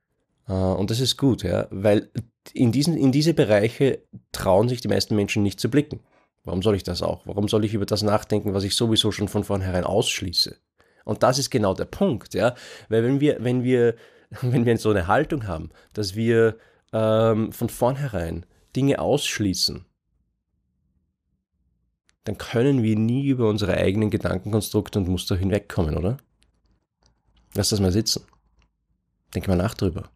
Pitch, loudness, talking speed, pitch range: 105 Hz, -23 LUFS, 165 wpm, 95-115 Hz